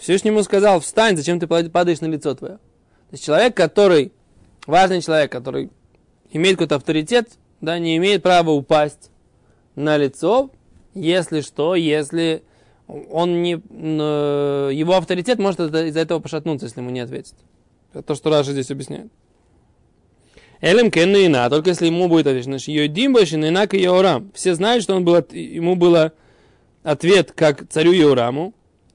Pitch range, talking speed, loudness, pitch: 150-185 Hz, 150 wpm, -17 LUFS, 165 Hz